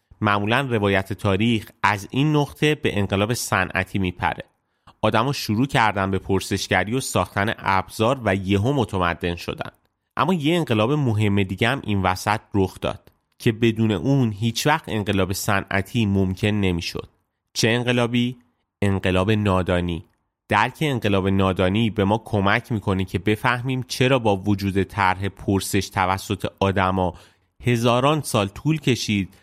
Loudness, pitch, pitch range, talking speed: -22 LUFS, 105 Hz, 95-120 Hz, 135 wpm